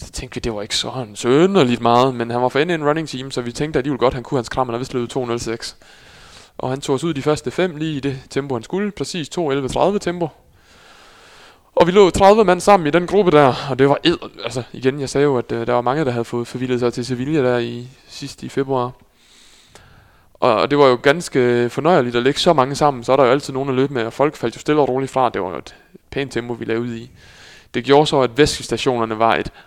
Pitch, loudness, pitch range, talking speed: 130 Hz, -18 LUFS, 120-145 Hz, 265 wpm